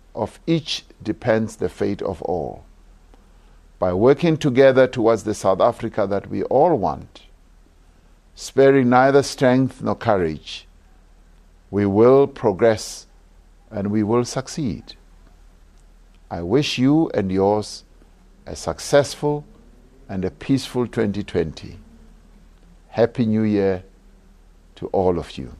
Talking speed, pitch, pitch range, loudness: 115 wpm, 105 Hz, 85-125 Hz, -20 LUFS